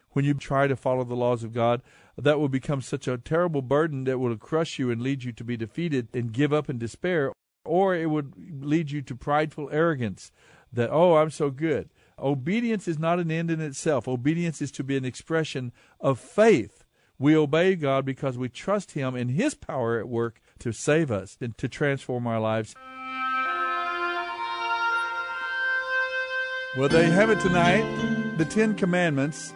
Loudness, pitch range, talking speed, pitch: -26 LUFS, 125-170 Hz, 175 wpm, 145 Hz